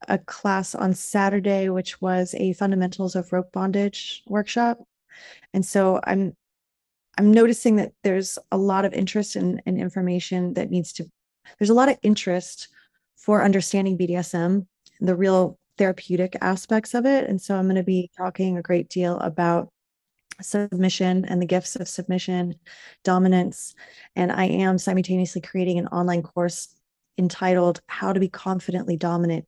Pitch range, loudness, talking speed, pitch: 180-195 Hz, -23 LUFS, 155 wpm, 185 Hz